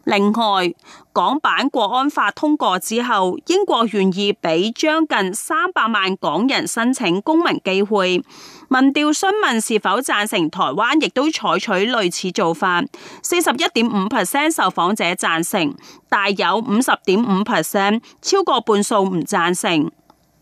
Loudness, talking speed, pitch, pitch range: -18 LUFS, 245 characters per minute, 220 Hz, 195-300 Hz